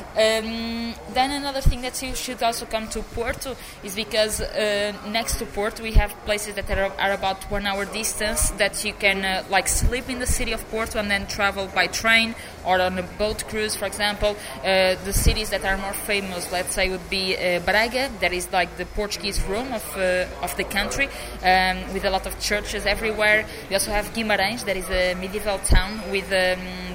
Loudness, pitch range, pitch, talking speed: -23 LUFS, 190-220 Hz, 205 Hz, 205 wpm